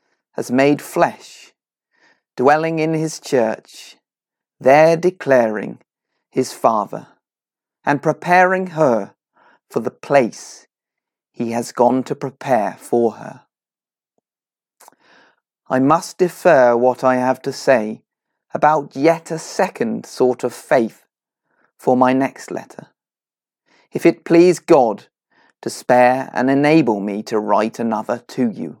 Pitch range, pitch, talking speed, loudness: 125-160 Hz, 140 Hz, 120 wpm, -17 LUFS